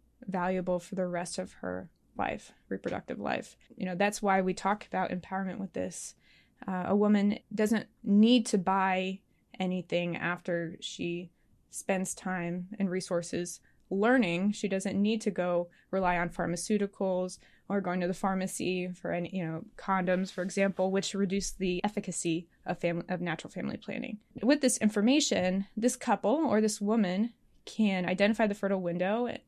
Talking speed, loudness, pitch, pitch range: 155 wpm, -31 LUFS, 190 Hz, 180-210 Hz